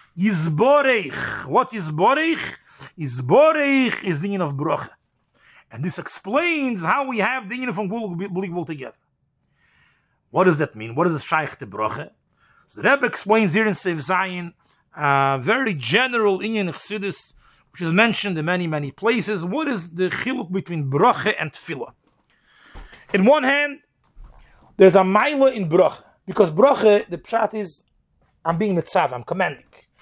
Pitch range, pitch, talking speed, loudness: 170-225 Hz, 190 Hz, 155 wpm, -20 LUFS